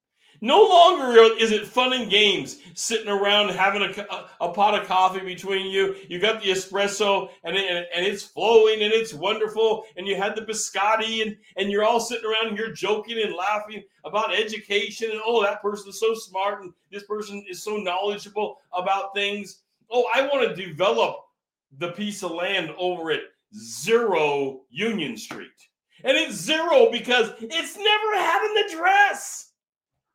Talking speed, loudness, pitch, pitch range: 170 wpm, -22 LUFS, 205 Hz, 195-225 Hz